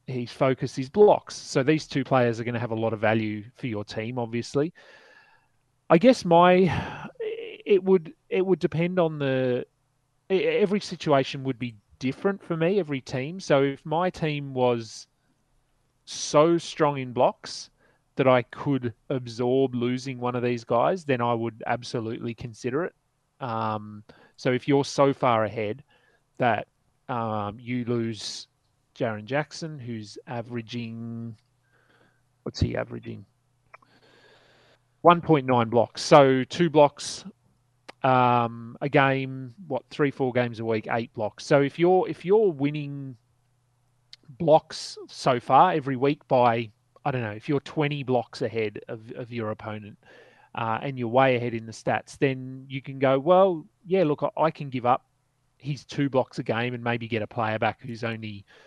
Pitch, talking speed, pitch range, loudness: 130 Hz, 160 wpm, 120-145 Hz, -25 LUFS